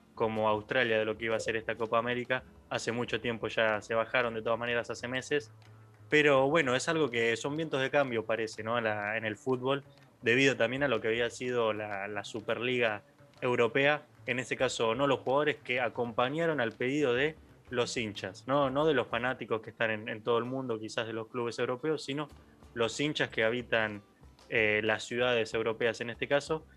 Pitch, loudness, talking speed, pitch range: 120 Hz, -31 LUFS, 200 wpm, 110-135 Hz